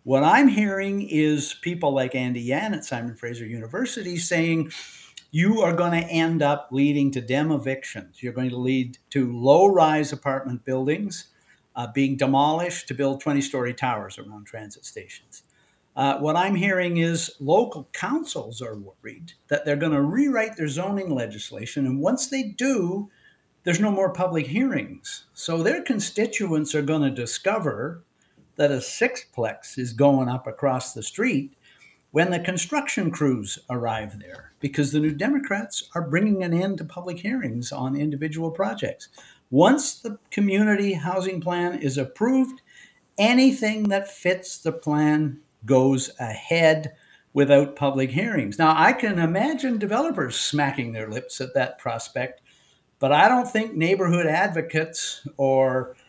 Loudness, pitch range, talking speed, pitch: -23 LUFS, 135-195 Hz, 150 wpm, 155 Hz